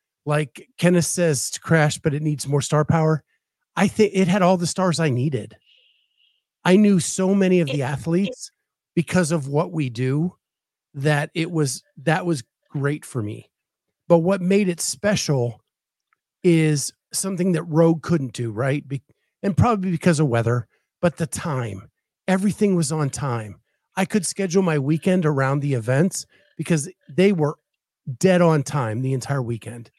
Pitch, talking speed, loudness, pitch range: 160 Hz, 165 wpm, -21 LUFS, 140-185 Hz